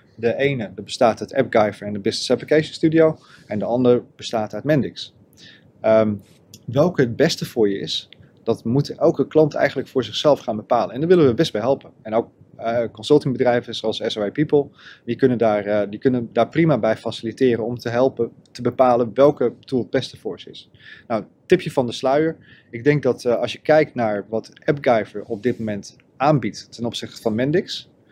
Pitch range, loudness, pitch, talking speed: 110-145 Hz, -20 LUFS, 120 Hz, 195 wpm